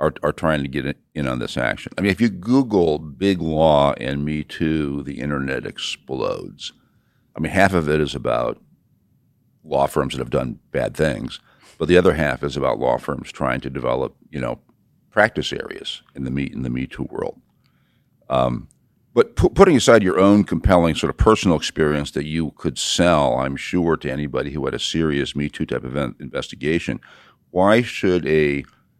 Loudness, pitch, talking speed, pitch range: -20 LUFS, 75 Hz, 190 wpm, 70-85 Hz